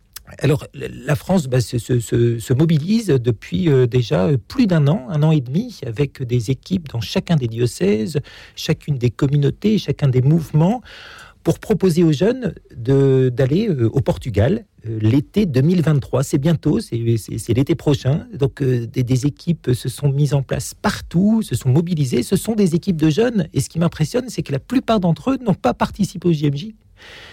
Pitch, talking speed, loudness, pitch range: 150 Hz, 180 wpm, -19 LUFS, 130-180 Hz